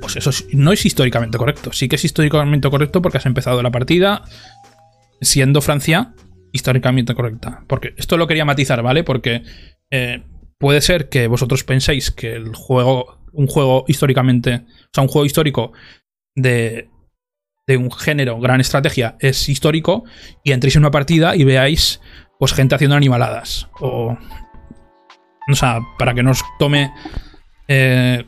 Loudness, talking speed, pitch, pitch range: -15 LUFS, 155 wpm, 130 Hz, 120-145 Hz